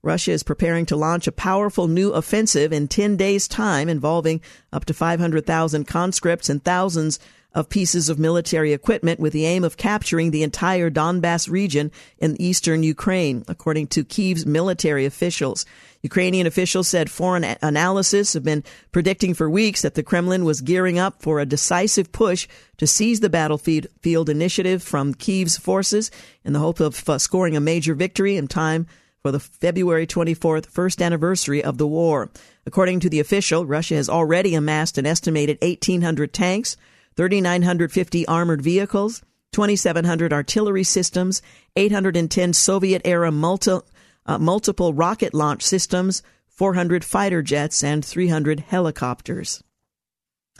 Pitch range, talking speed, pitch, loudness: 155-185 Hz, 145 wpm, 170 Hz, -20 LUFS